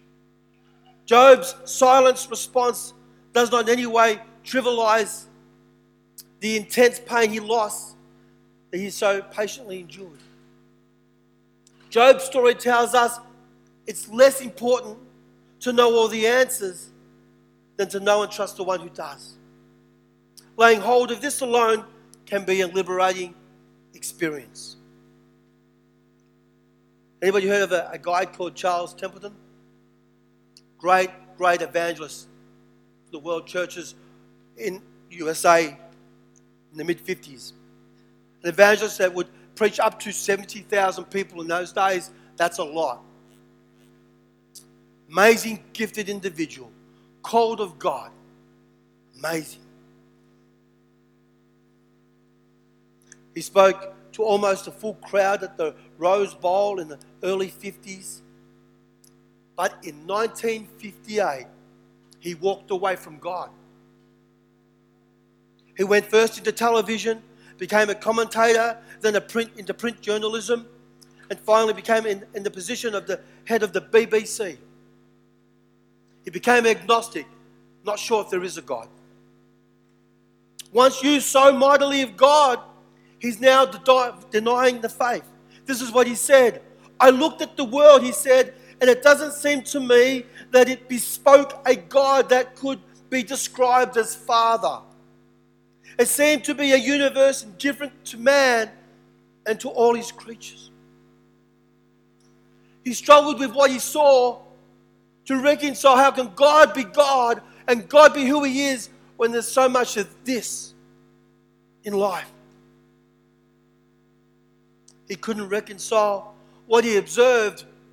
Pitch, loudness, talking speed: 195 Hz, -20 LUFS, 120 wpm